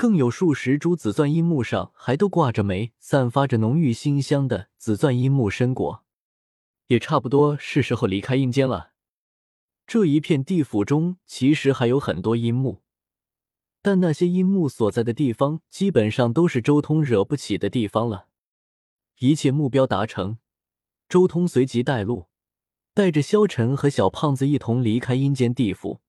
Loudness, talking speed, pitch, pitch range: -22 LUFS, 245 characters per minute, 130 Hz, 115-155 Hz